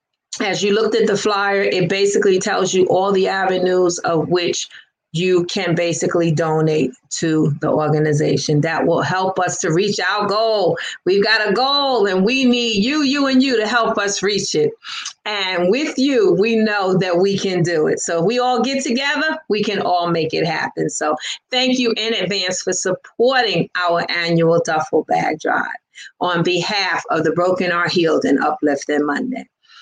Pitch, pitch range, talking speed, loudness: 190 Hz, 170-230 Hz, 180 wpm, -17 LUFS